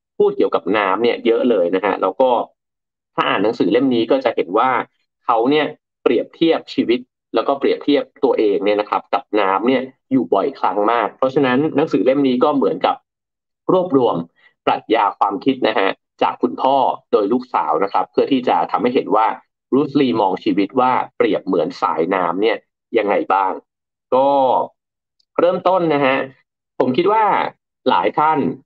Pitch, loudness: 310 Hz, -17 LUFS